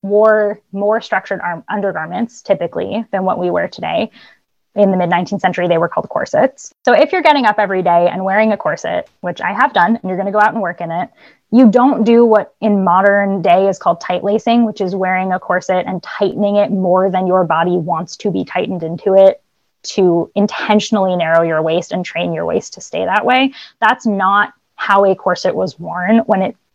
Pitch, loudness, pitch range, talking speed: 195 Hz, -14 LUFS, 180-215 Hz, 215 wpm